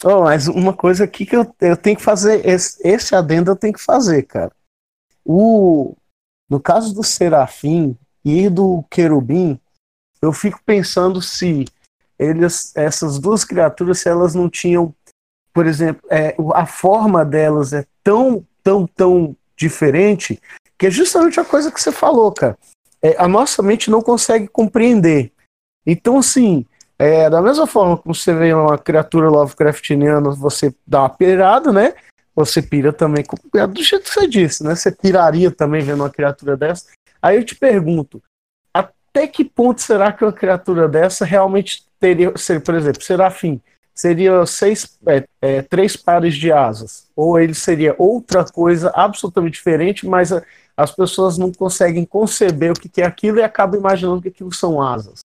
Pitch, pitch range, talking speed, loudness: 180 Hz, 155-200 Hz, 160 wpm, -14 LUFS